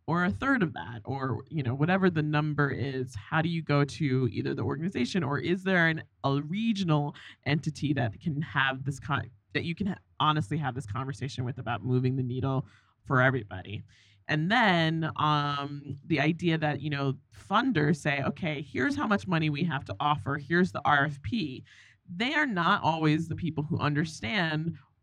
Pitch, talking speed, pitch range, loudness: 145 Hz, 185 wpm, 130-160 Hz, -29 LUFS